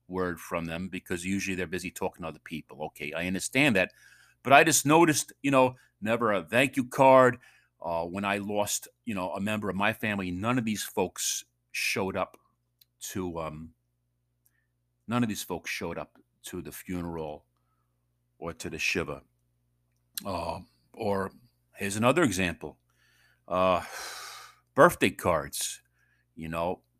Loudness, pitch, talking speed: -28 LUFS, 90 Hz, 150 wpm